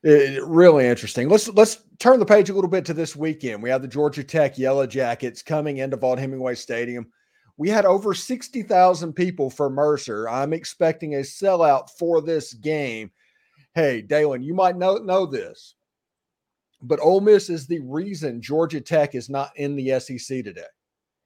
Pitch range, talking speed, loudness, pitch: 135-180 Hz, 175 wpm, -21 LUFS, 150 Hz